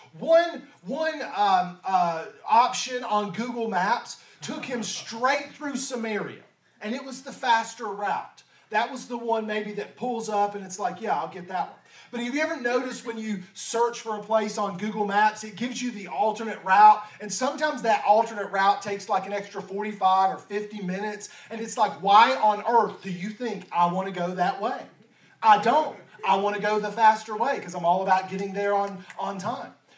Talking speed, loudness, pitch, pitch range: 200 wpm, -25 LUFS, 215 Hz, 200-240 Hz